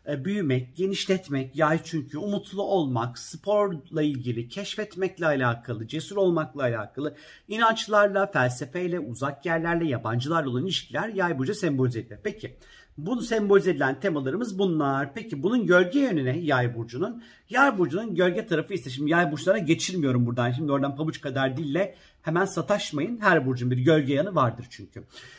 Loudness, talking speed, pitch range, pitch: -26 LUFS, 140 wpm, 135-190 Hz, 160 Hz